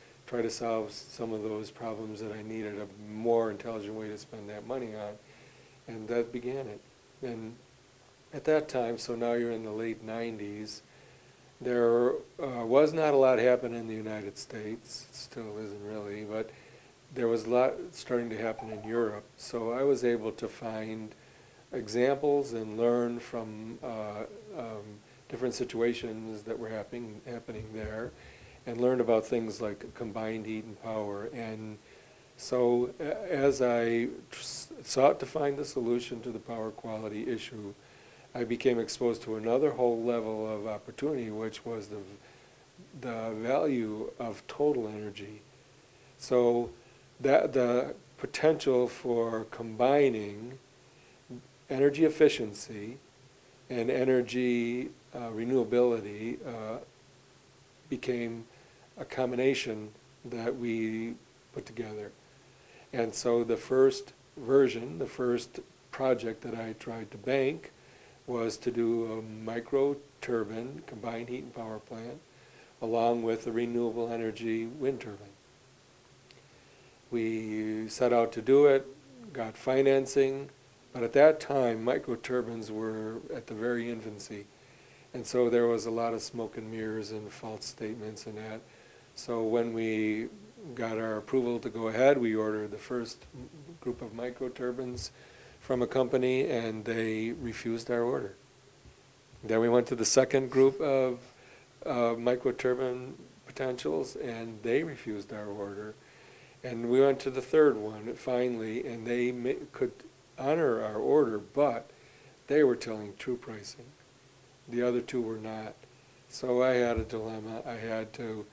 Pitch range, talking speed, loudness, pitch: 110-125 Hz, 140 wpm, -31 LUFS, 115 Hz